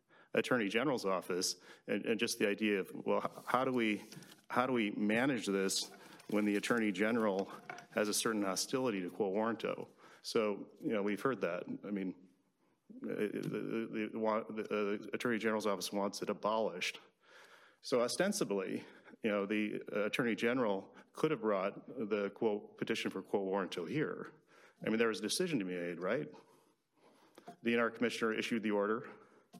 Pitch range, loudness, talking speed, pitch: 100-115 Hz, -36 LUFS, 170 wpm, 105 Hz